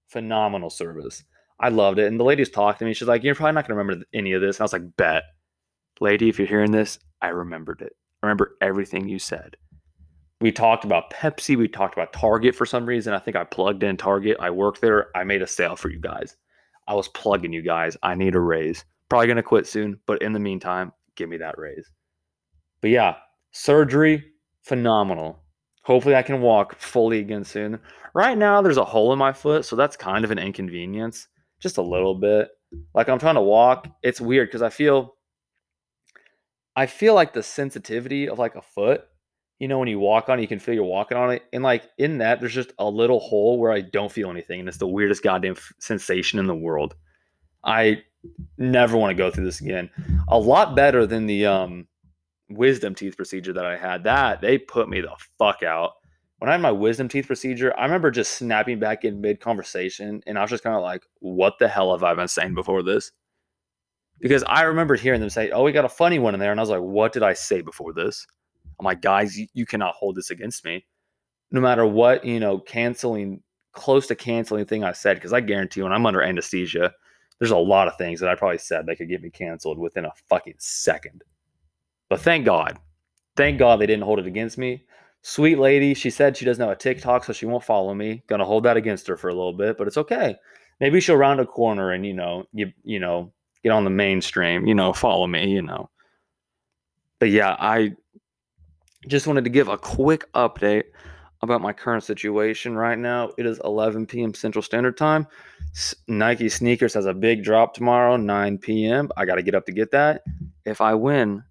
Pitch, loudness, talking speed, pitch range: 105 Hz, -21 LUFS, 220 wpm, 95-120 Hz